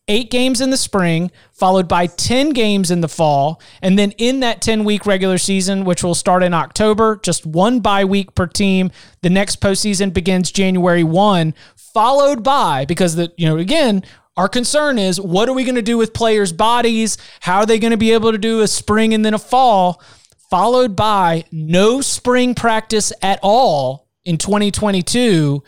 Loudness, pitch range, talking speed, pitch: -15 LUFS, 180-225 Hz, 185 wpm, 200 Hz